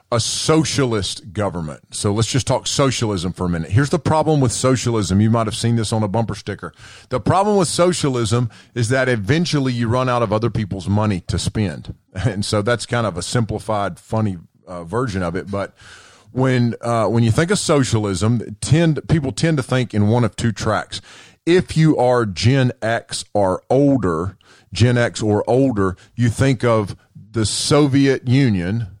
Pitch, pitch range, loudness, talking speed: 115 Hz, 105-130 Hz, -18 LUFS, 180 wpm